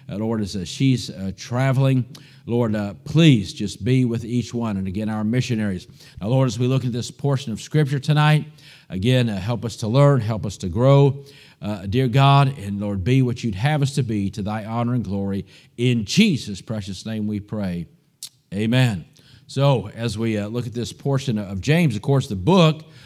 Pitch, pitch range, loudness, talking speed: 120 Hz, 105-140 Hz, -21 LUFS, 205 wpm